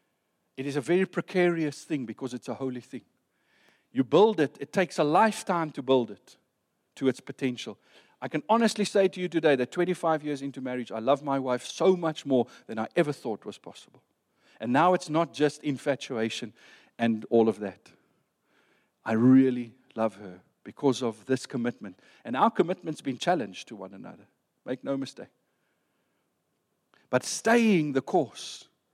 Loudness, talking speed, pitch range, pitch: -27 LUFS, 170 wpm, 125-165 Hz, 135 Hz